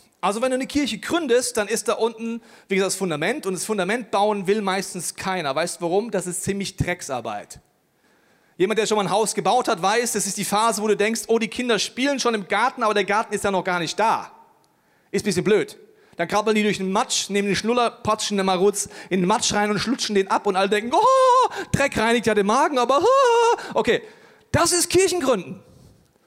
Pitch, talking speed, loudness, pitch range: 215 Hz, 225 wpm, -21 LUFS, 195-250 Hz